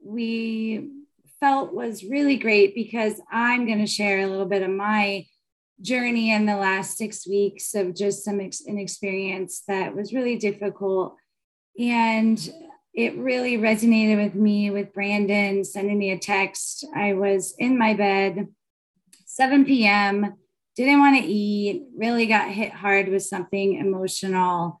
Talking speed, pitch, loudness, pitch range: 145 wpm, 205 Hz, -22 LUFS, 195-225 Hz